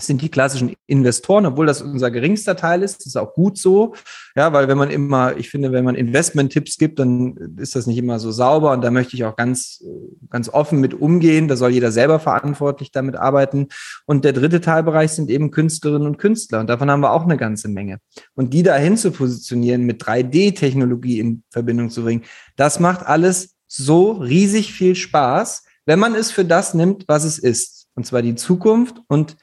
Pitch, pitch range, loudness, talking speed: 145 Hz, 125-170 Hz, -17 LUFS, 200 wpm